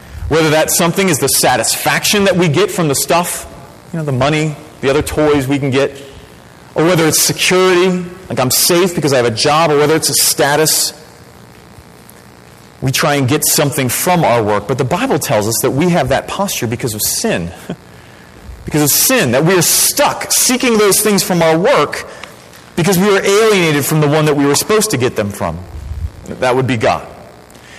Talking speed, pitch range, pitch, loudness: 200 wpm, 105-170 Hz, 145 Hz, -12 LUFS